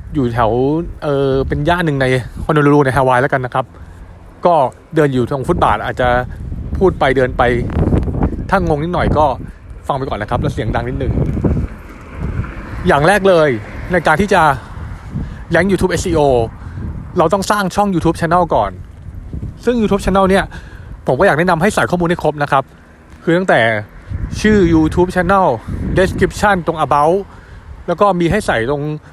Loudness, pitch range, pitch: -14 LUFS, 110-175 Hz, 145 Hz